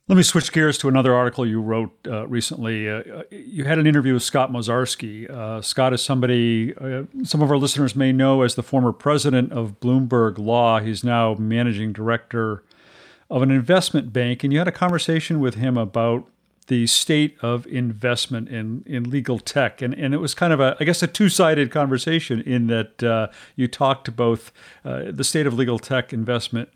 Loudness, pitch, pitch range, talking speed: -20 LUFS, 125 Hz, 115-140 Hz, 195 wpm